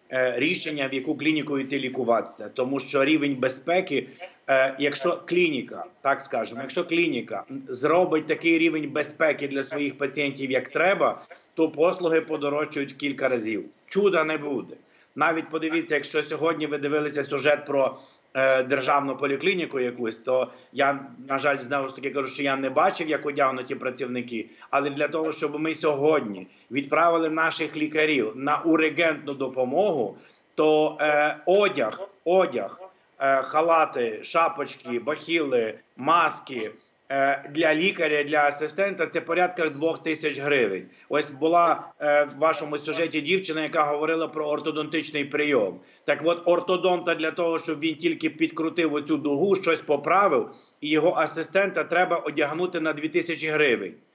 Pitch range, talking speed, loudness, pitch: 140-165 Hz, 135 wpm, -24 LUFS, 150 Hz